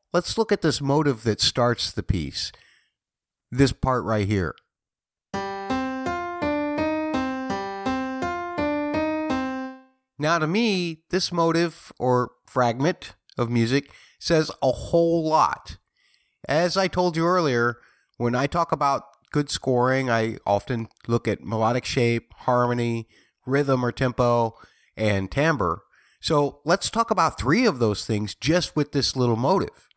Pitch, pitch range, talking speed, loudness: 145 Hz, 120-195 Hz, 125 wpm, -24 LUFS